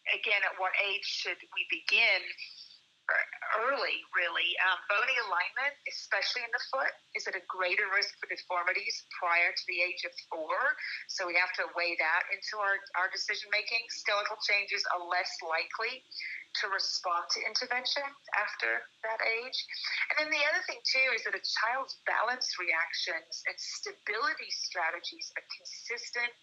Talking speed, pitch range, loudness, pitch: 155 wpm, 185-260 Hz, -31 LUFS, 210 Hz